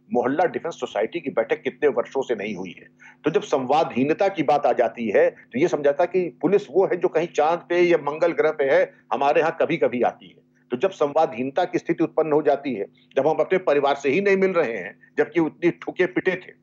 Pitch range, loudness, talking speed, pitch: 150-190 Hz, -22 LUFS, 235 wpm, 170 Hz